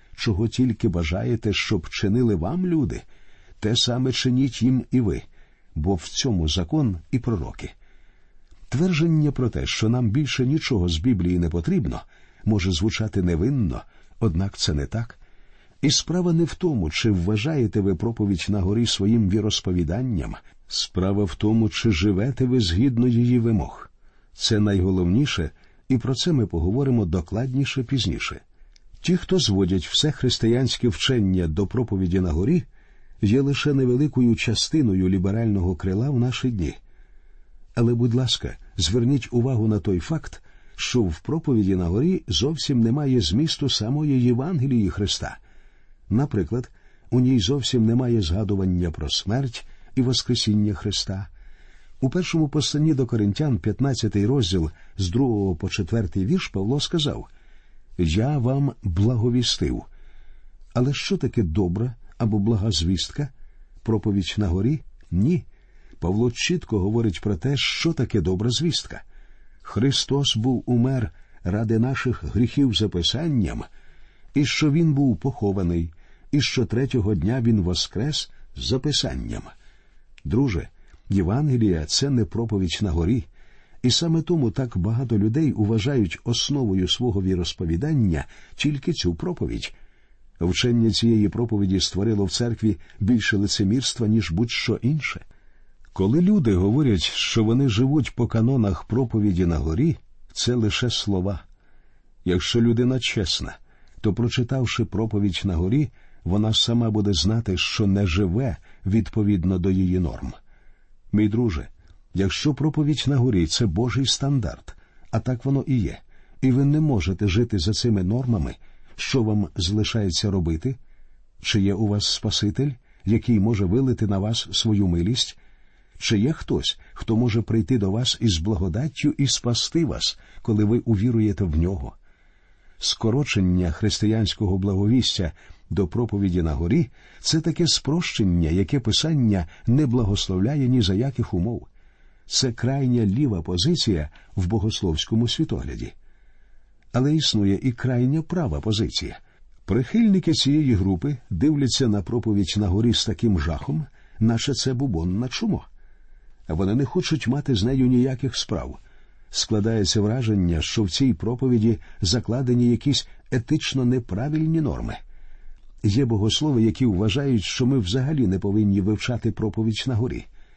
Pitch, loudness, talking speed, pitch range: 110 Hz, -22 LUFS, 130 wpm, 95-130 Hz